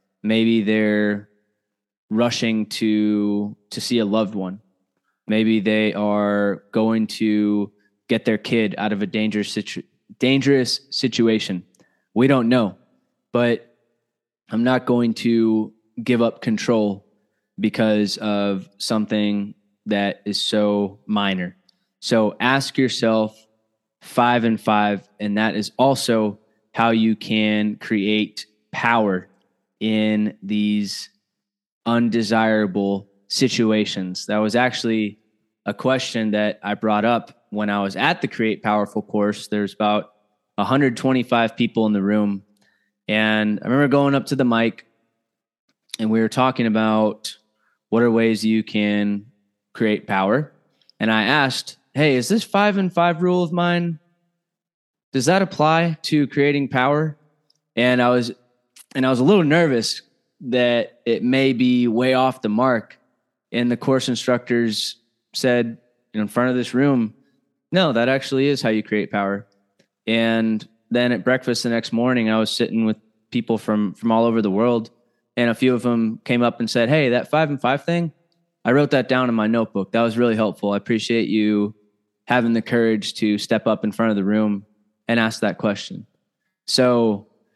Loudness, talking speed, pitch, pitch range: -20 LUFS, 155 wpm, 110 Hz, 105-125 Hz